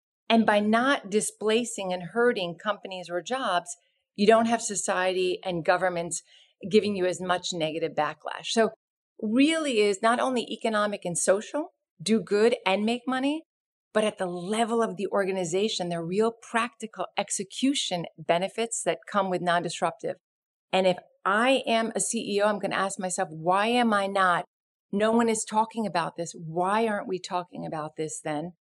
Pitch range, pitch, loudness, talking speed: 180-225 Hz, 200 Hz, -27 LUFS, 165 wpm